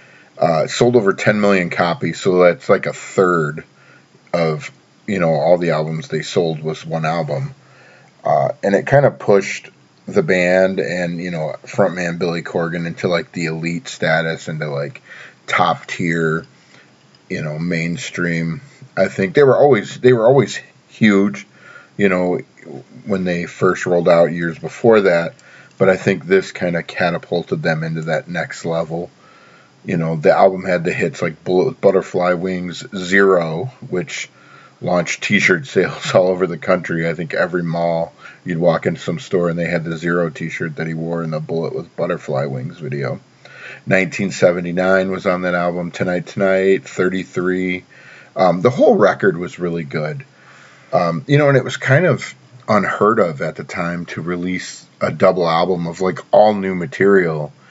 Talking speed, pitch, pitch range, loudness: 170 wpm, 90 Hz, 85-95 Hz, -17 LUFS